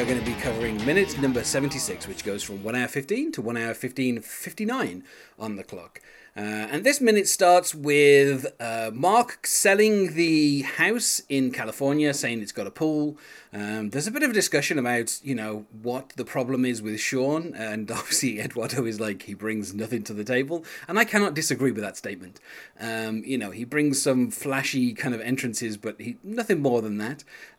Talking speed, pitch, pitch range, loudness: 195 wpm, 130 Hz, 110-150 Hz, -25 LUFS